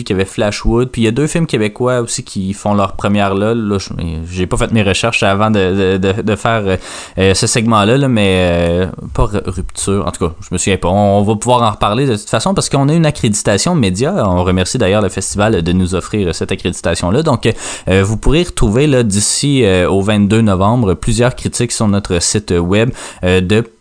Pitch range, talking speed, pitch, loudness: 95-120 Hz, 215 wpm, 105 Hz, -13 LUFS